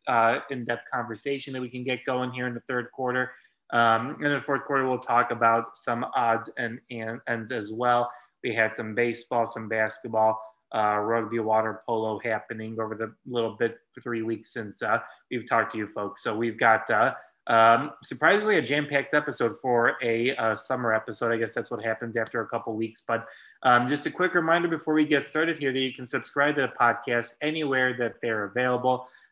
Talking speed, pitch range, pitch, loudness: 205 wpm, 115-130 Hz, 120 Hz, -26 LUFS